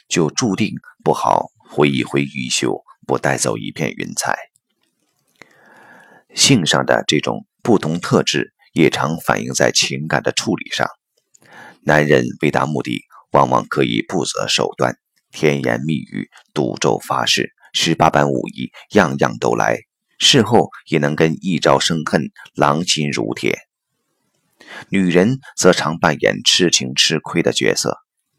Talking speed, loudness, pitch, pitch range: 200 characters per minute, -17 LUFS, 75 Hz, 70-80 Hz